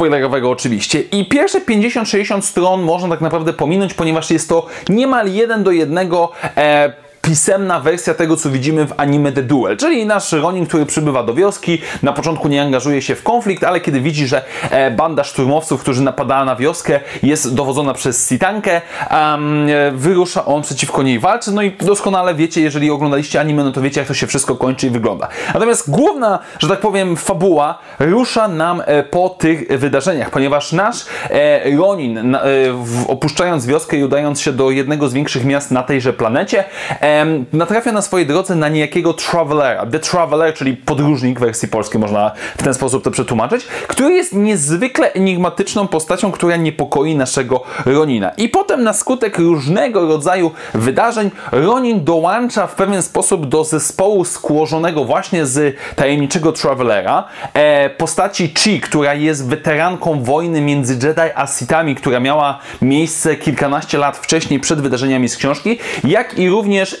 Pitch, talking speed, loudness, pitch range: 155 Hz, 160 wpm, -14 LUFS, 140-180 Hz